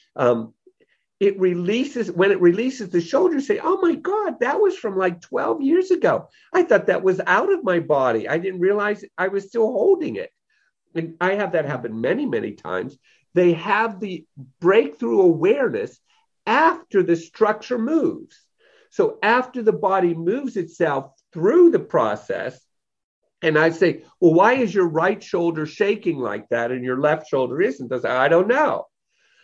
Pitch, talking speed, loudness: 205 Hz, 170 wpm, -20 LUFS